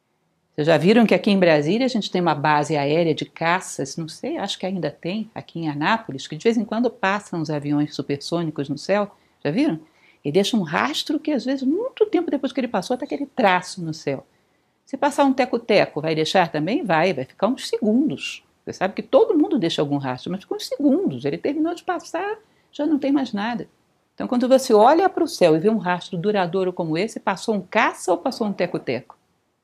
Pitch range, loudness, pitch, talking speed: 165-265 Hz, -21 LUFS, 205 Hz, 220 wpm